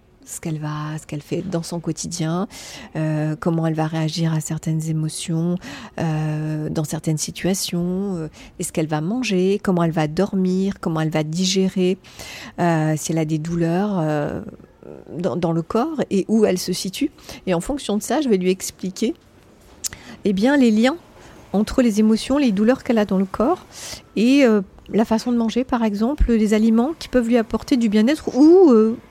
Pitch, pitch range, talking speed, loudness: 185 Hz, 160-220 Hz, 190 wpm, -20 LUFS